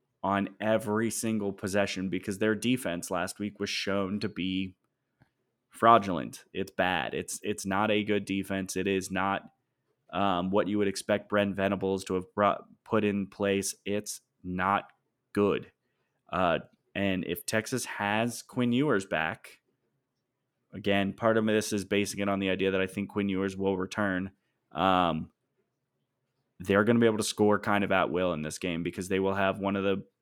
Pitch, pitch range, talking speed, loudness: 100 Hz, 95-105 Hz, 175 wpm, -29 LUFS